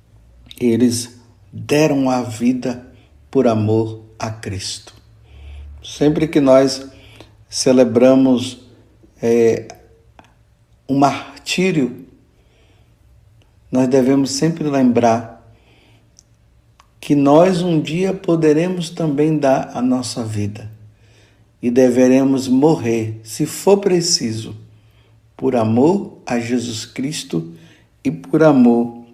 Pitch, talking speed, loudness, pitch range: 120 Hz, 90 wpm, -16 LUFS, 110-140 Hz